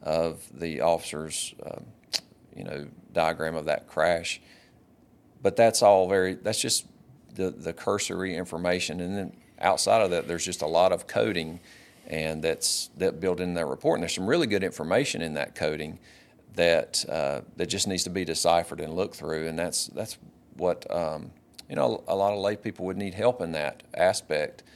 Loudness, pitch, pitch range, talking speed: -27 LUFS, 85 Hz, 80-95 Hz, 185 wpm